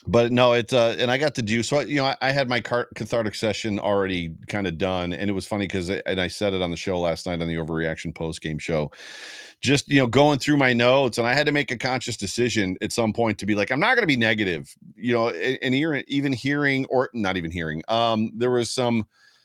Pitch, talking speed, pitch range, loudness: 115 Hz, 260 wpm, 95-130 Hz, -23 LUFS